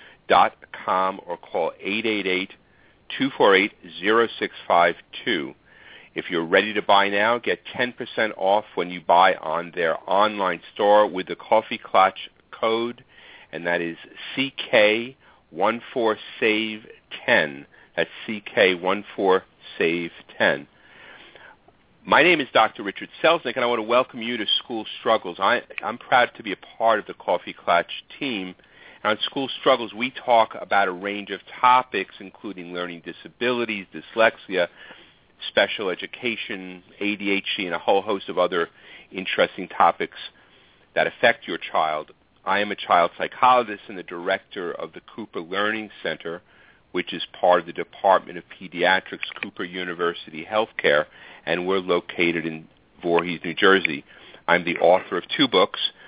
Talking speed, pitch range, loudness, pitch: 135 wpm, 90-115 Hz, -22 LUFS, 100 Hz